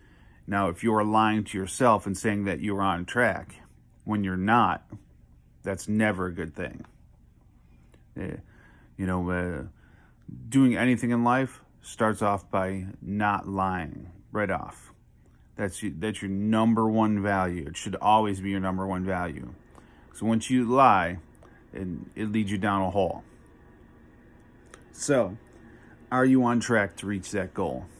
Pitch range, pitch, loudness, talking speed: 95-110 Hz, 100 Hz, -26 LUFS, 150 wpm